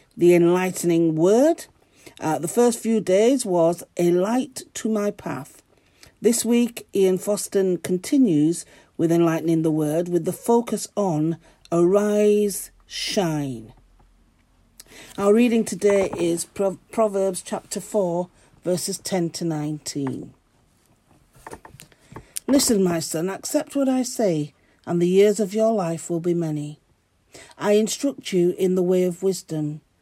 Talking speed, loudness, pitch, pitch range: 130 wpm, -22 LUFS, 185 Hz, 165-210 Hz